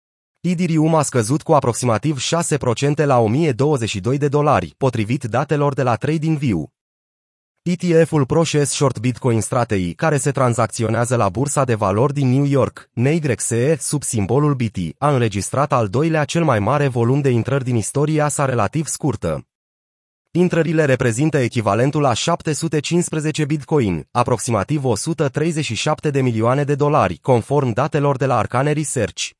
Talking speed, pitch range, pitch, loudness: 135 wpm, 120-155 Hz, 140 Hz, -18 LUFS